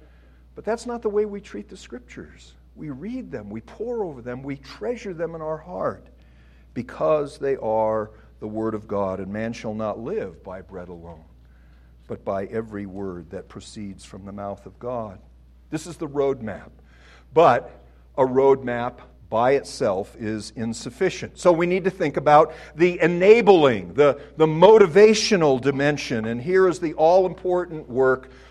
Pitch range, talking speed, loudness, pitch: 95-160 Hz, 165 wpm, -21 LUFS, 125 Hz